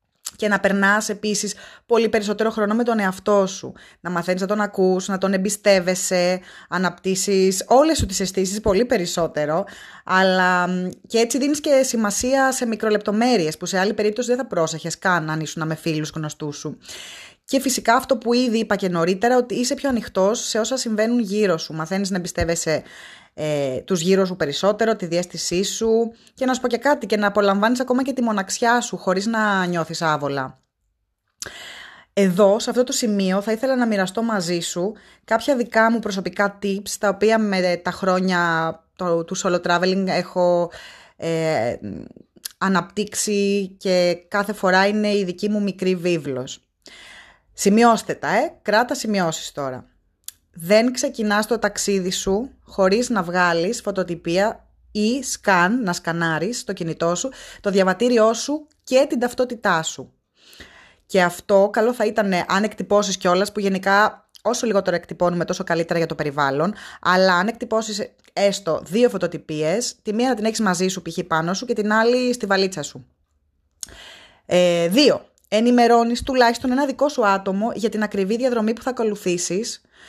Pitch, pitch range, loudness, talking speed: 200 Hz, 180-225 Hz, -20 LUFS, 160 wpm